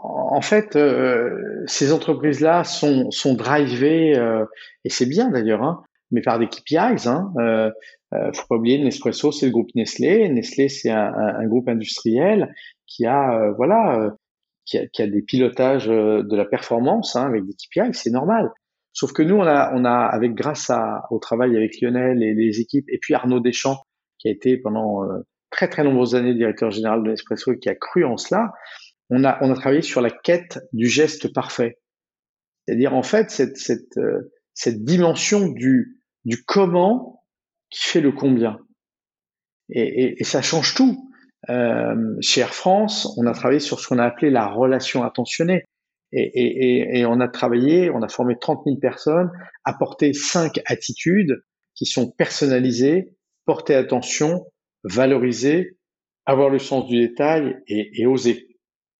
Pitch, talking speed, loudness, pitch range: 130 Hz, 175 wpm, -20 LUFS, 120-160 Hz